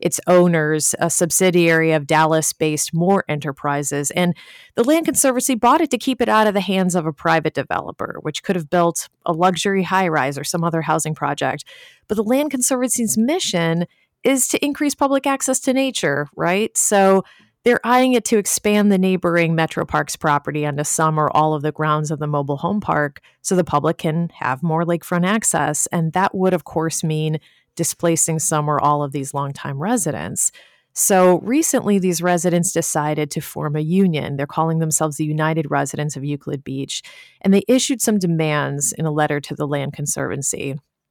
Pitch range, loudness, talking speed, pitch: 150-200 Hz, -18 LUFS, 185 wpm, 170 Hz